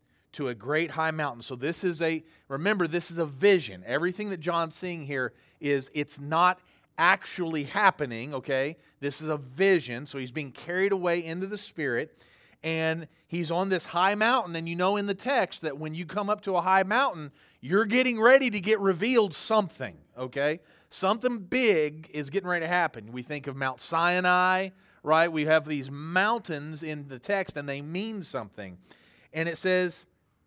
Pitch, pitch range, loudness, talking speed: 165 Hz, 145-190 Hz, -27 LUFS, 185 wpm